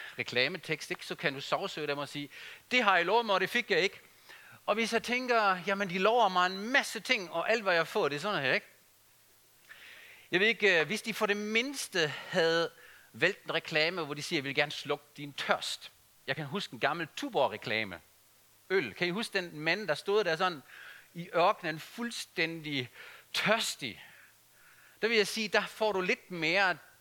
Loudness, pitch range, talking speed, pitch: -31 LUFS, 145-215 Hz, 200 wpm, 175 Hz